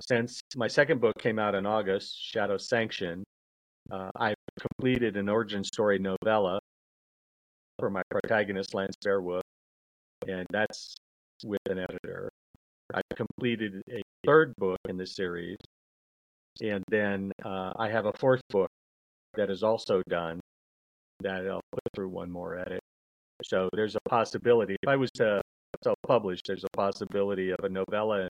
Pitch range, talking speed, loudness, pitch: 90-110 Hz, 145 wpm, -30 LUFS, 100 Hz